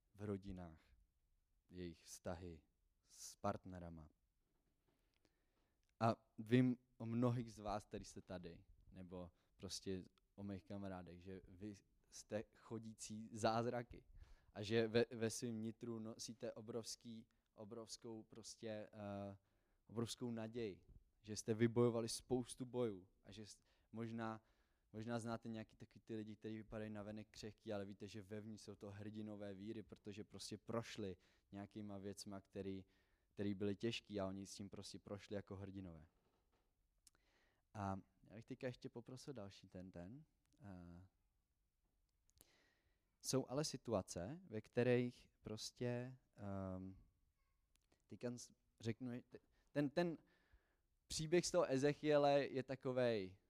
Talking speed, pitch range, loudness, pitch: 120 wpm, 95-115 Hz, -47 LUFS, 105 Hz